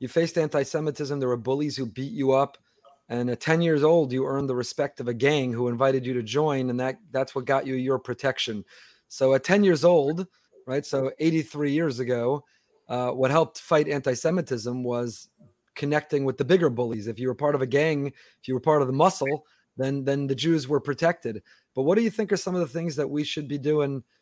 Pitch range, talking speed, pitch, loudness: 130-155 Hz, 225 wpm, 140 Hz, -25 LUFS